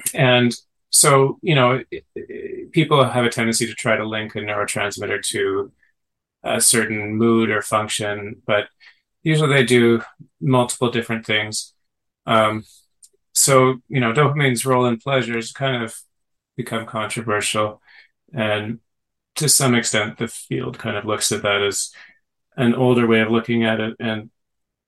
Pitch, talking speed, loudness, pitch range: 115 Hz, 140 wpm, -19 LUFS, 110-130 Hz